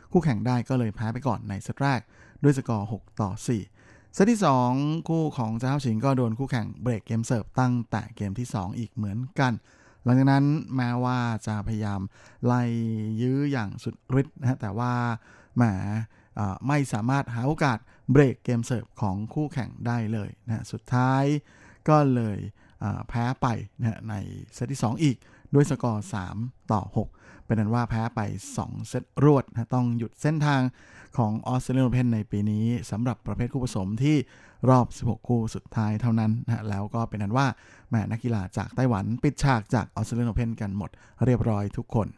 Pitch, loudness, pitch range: 120 Hz, -27 LUFS, 110-130 Hz